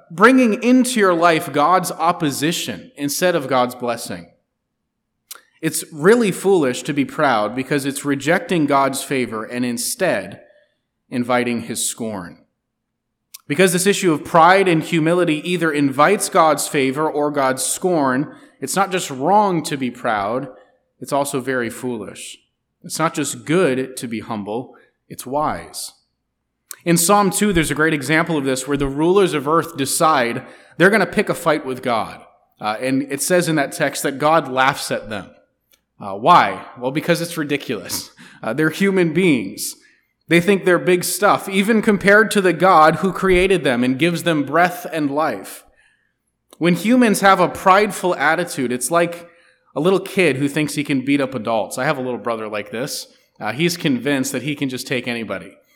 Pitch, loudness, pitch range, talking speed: 155 Hz, -18 LUFS, 130-180 Hz, 170 wpm